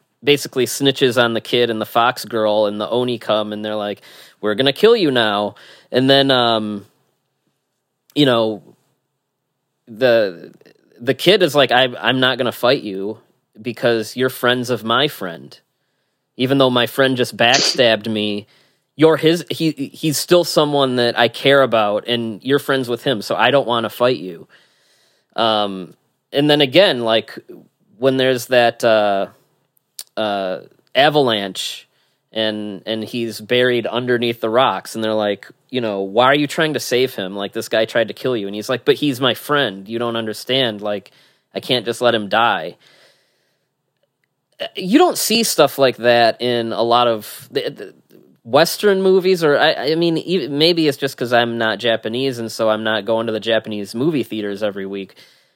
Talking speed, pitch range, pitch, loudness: 175 wpm, 110-135 Hz, 120 Hz, -17 LUFS